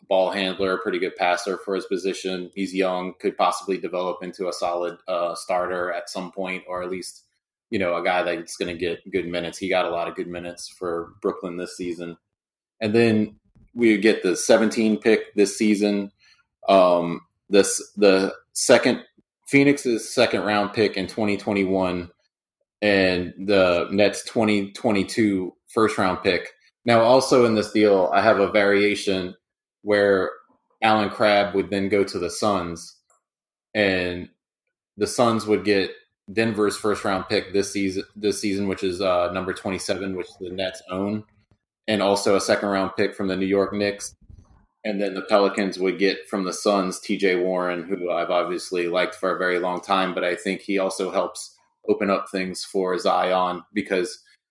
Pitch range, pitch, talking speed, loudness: 90-105 Hz, 95 Hz, 170 wpm, -22 LUFS